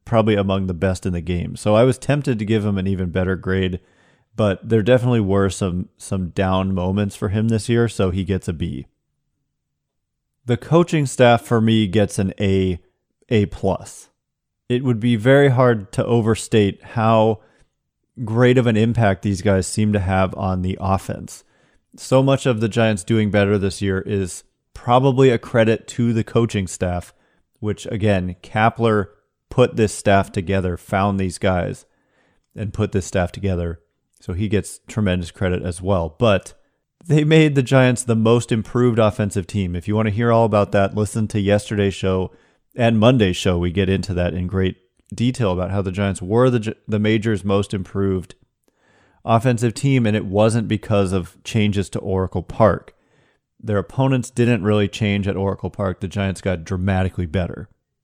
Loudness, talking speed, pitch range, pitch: -19 LUFS, 175 wpm, 95-115 Hz, 105 Hz